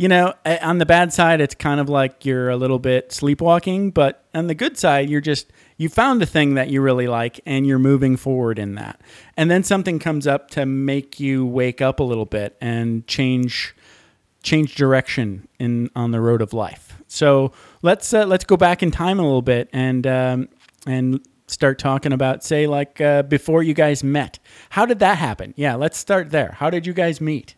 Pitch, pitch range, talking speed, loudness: 140 Hz, 130-160 Hz, 210 wpm, -19 LUFS